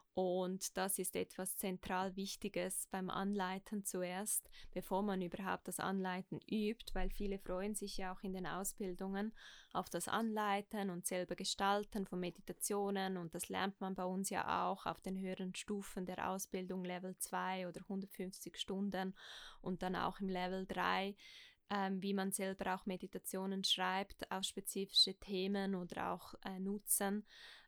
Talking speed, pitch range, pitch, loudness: 155 wpm, 185-200 Hz, 190 Hz, -41 LUFS